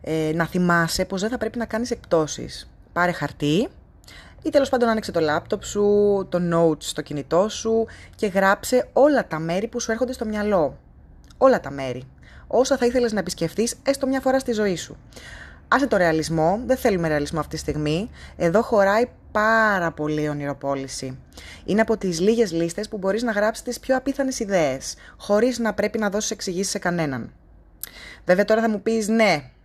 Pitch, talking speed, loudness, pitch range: 200 Hz, 180 wpm, -22 LUFS, 160-225 Hz